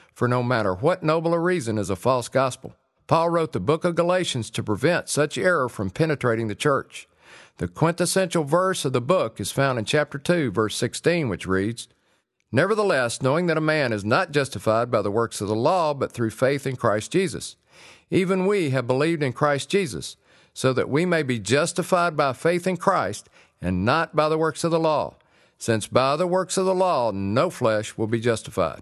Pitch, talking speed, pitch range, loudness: 140 Hz, 200 wpm, 115-170 Hz, -23 LUFS